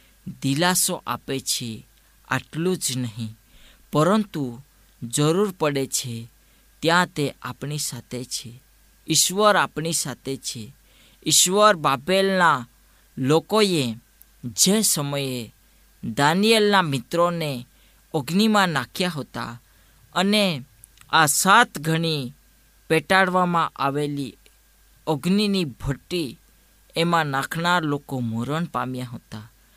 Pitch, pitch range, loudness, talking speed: 145 Hz, 125-180 Hz, -22 LUFS, 85 wpm